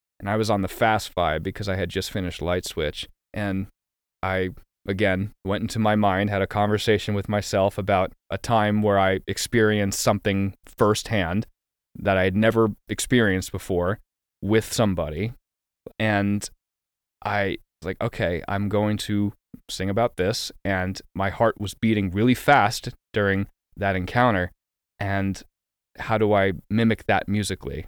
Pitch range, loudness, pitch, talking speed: 95-110 Hz, -24 LUFS, 100 Hz, 150 wpm